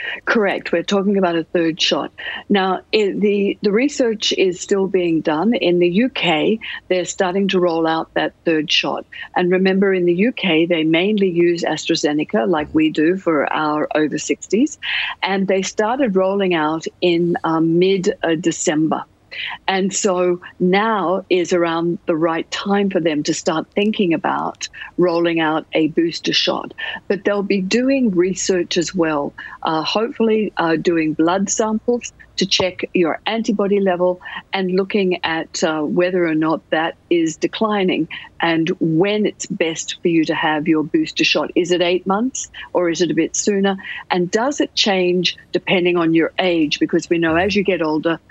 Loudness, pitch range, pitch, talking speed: -18 LUFS, 165-205 Hz, 180 Hz, 165 wpm